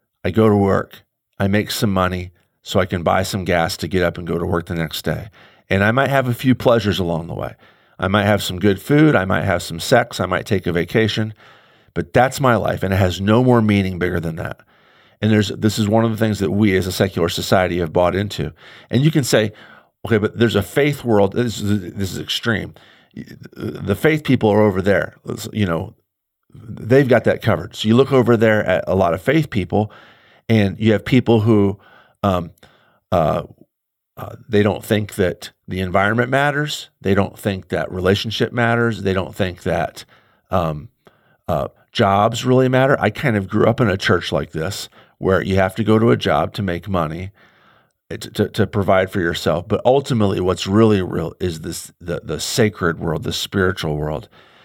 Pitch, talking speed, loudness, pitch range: 100 Hz, 210 wpm, -18 LUFS, 95-115 Hz